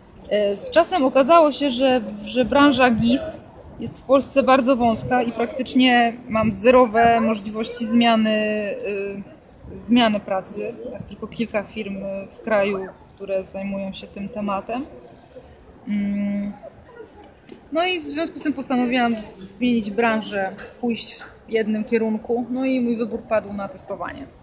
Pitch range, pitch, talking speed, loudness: 205-255 Hz, 230 Hz, 130 wpm, -21 LUFS